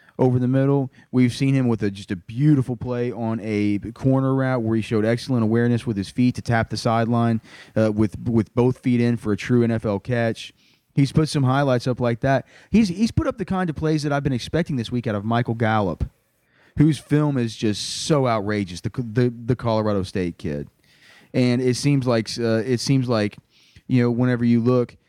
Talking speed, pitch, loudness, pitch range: 215 wpm, 120 Hz, -22 LUFS, 110-130 Hz